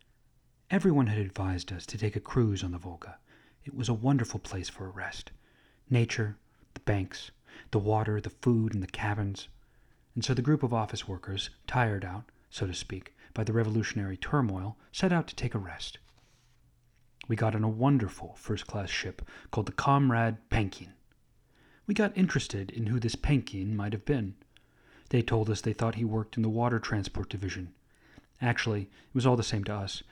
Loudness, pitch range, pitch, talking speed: -31 LUFS, 100-125 Hz, 110 Hz, 185 wpm